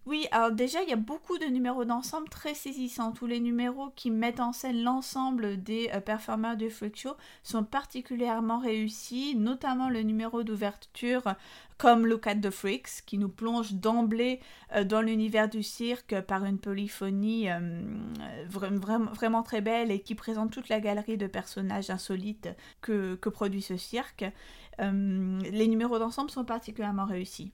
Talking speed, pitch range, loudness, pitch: 170 wpm, 205-240 Hz, -31 LUFS, 225 Hz